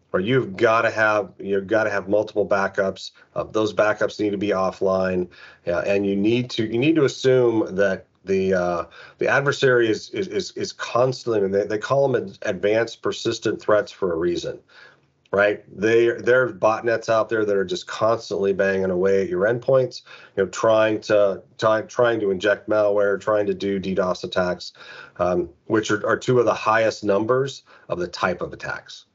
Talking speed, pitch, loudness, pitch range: 185 wpm, 105 Hz, -21 LUFS, 100-115 Hz